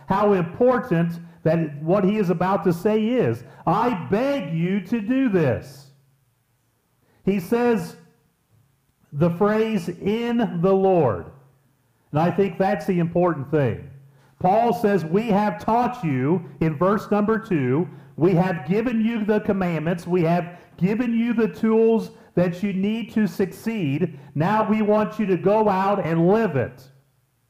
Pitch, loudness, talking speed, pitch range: 185 Hz, -22 LUFS, 145 wpm, 155-215 Hz